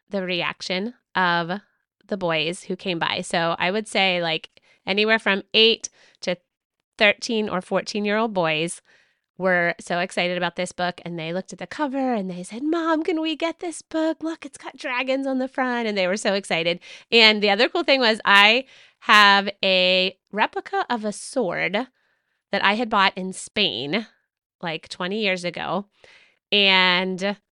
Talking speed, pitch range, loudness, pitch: 175 wpm, 180-240 Hz, -21 LUFS, 200 Hz